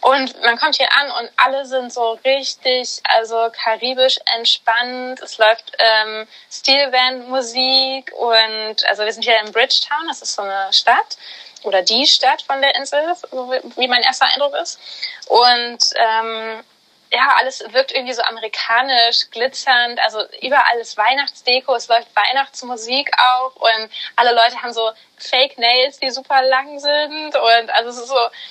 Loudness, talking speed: -15 LUFS, 155 wpm